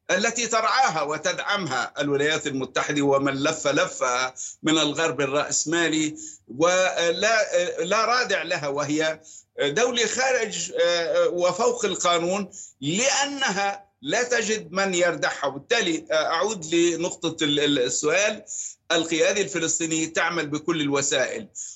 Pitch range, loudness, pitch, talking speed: 155-220 Hz, -23 LUFS, 170 Hz, 95 wpm